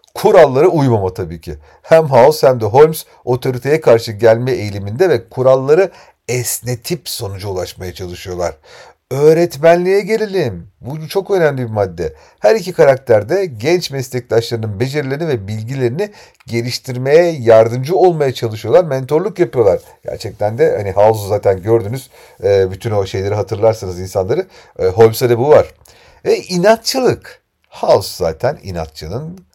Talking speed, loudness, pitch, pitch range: 125 wpm, -14 LUFS, 125 Hz, 110-165 Hz